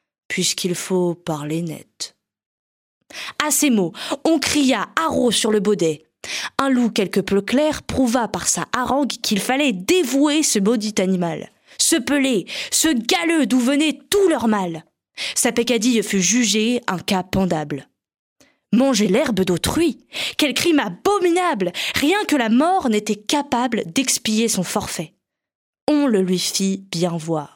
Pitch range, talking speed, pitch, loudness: 190-285 Hz, 140 wpm, 235 Hz, -19 LUFS